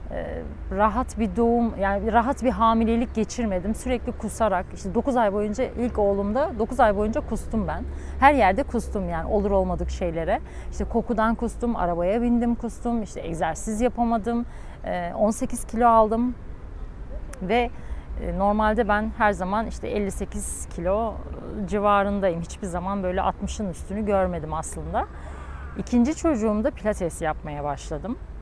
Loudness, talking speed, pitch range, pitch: -24 LUFS, 130 wpm, 195-235 Hz, 215 Hz